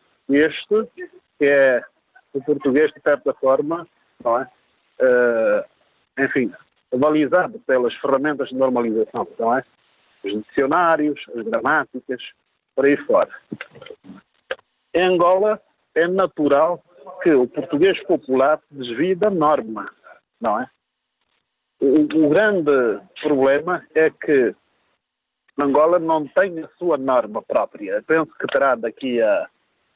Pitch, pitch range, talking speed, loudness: 150 Hz, 135-180 Hz, 115 wpm, -19 LUFS